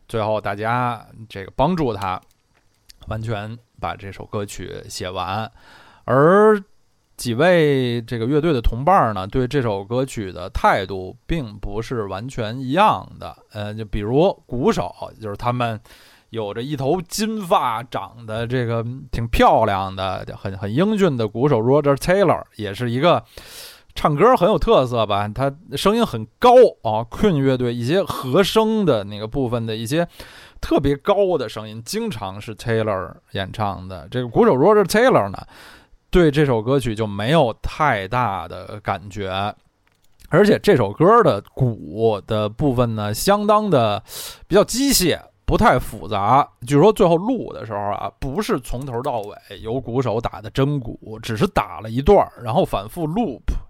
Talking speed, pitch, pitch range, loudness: 255 characters per minute, 115 Hz, 105-145 Hz, -19 LUFS